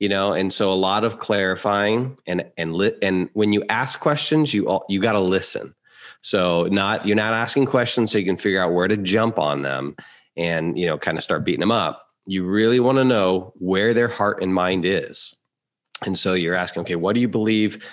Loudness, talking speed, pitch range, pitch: -21 LUFS, 220 wpm, 95-115 Hz, 100 Hz